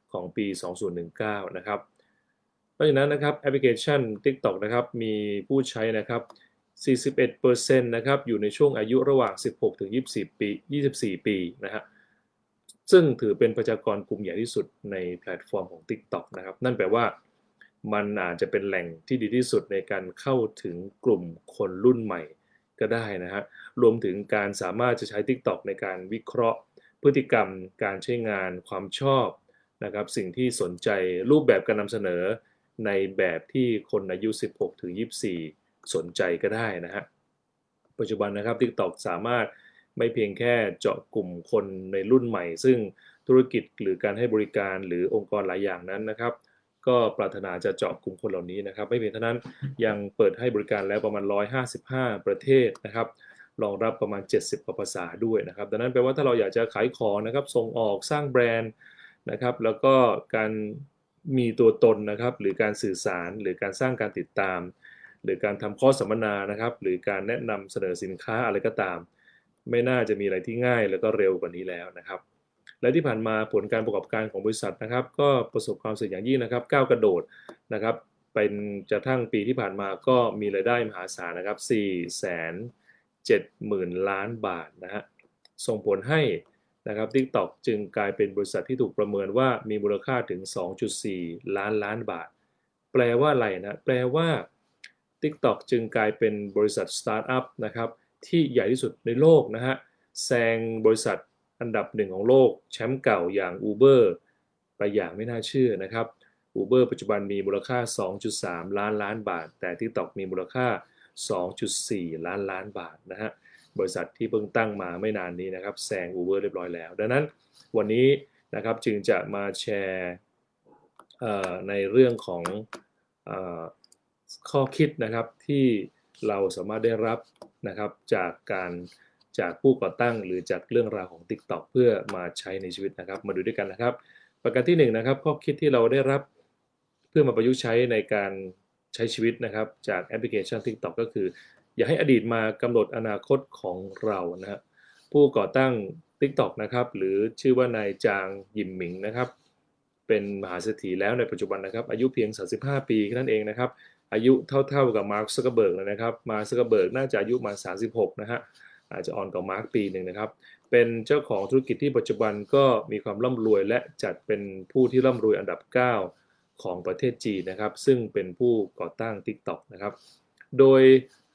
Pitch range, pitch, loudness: 100-130 Hz, 115 Hz, -26 LUFS